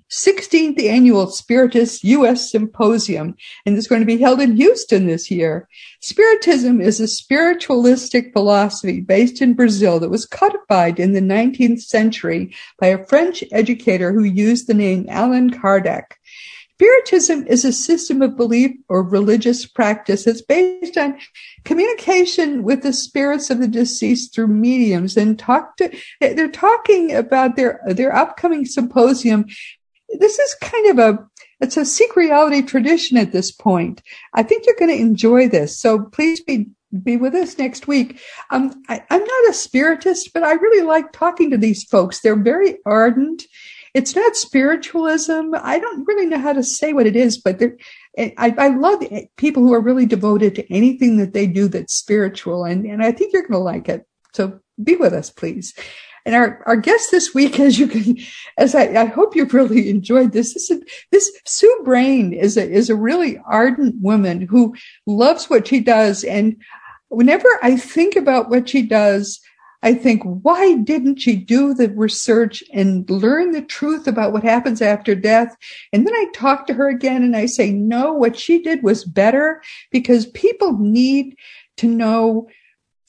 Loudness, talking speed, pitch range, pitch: -15 LUFS, 170 wpm, 220-310 Hz, 250 Hz